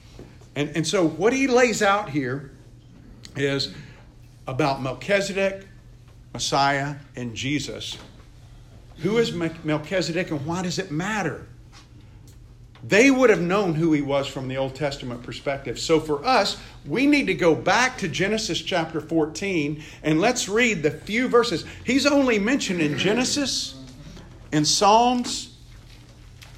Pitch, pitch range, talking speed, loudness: 155 Hz, 130-195 Hz, 135 wpm, -22 LUFS